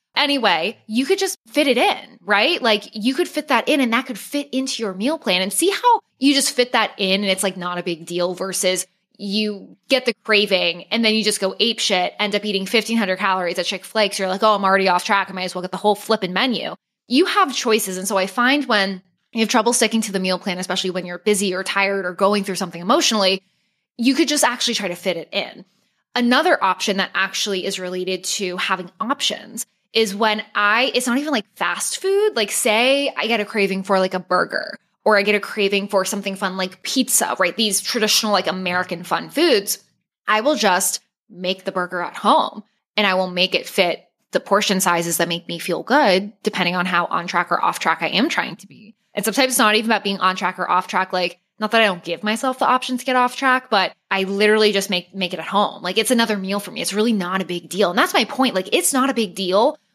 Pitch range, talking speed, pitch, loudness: 185-235 Hz, 245 wpm, 205 Hz, -19 LUFS